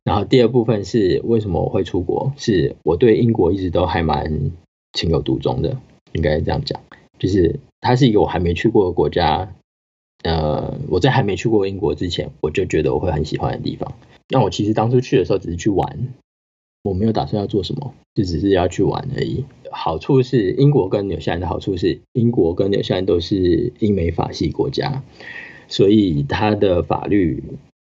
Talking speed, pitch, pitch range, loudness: 290 characters per minute, 100 Hz, 80-120 Hz, -18 LUFS